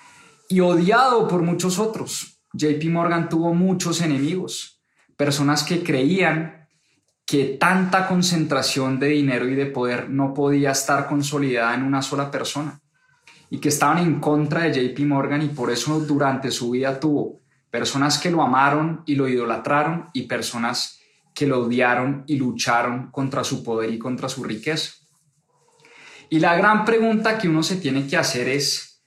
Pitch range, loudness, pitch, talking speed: 135-165 Hz, -21 LUFS, 145 Hz, 155 wpm